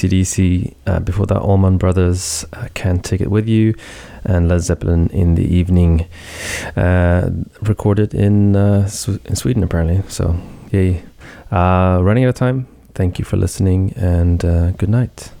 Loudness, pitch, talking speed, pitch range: -16 LUFS, 95 Hz, 160 wpm, 90-105 Hz